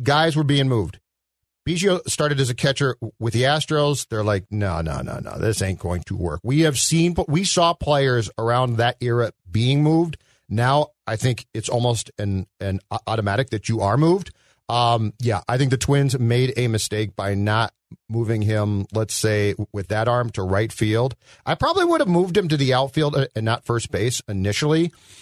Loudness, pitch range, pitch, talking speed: -21 LUFS, 105-140 Hz, 120 Hz, 195 wpm